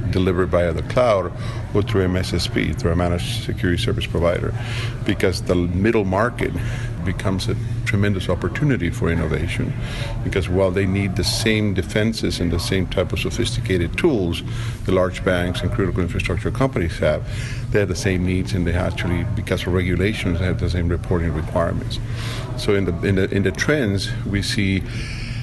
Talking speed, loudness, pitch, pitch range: 170 wpm, -21 LUFS, 100 Hz, 90-115 Hz